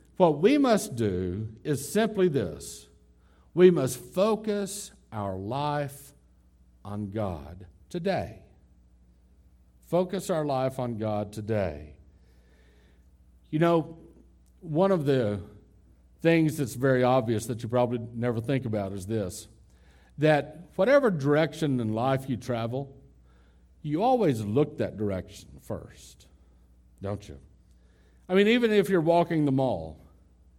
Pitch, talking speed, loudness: 110 Hz, 120 wpm, -27 LUFS